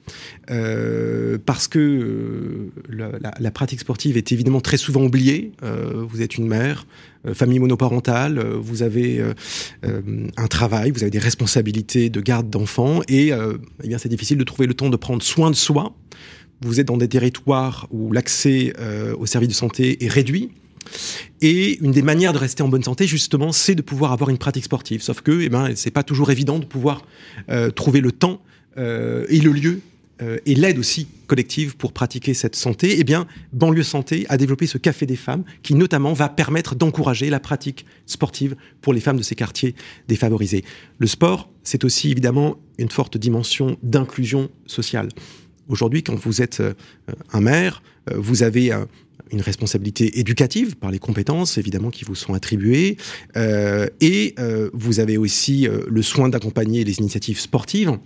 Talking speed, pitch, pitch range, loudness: 185 wpm, 130 Hz, 115-145 Hz, -19 LUFS